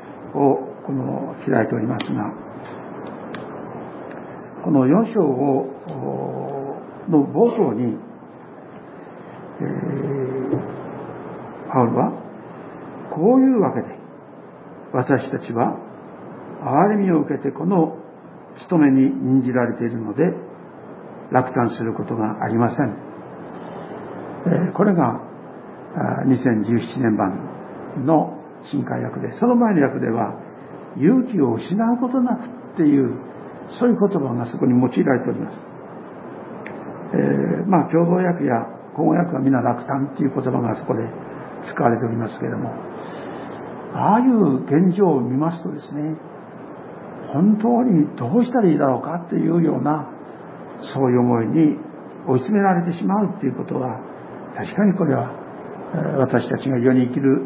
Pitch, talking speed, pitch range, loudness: 145 Hz, 240 characters per minute, 125-190 Hz, -20 LUFS